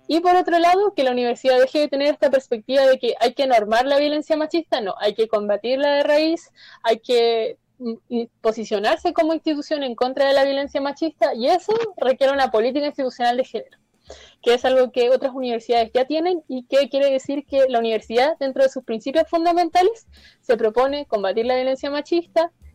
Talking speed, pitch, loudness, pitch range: 185 wpm, 270 Hz, -20 LUFS, 240-310 Hz